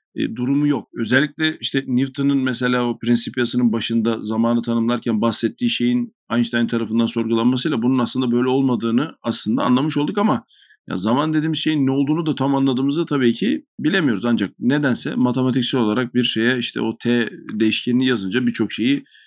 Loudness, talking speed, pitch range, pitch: -19 LUFS, 155 wpm, 115-145 Hz, 125 Hz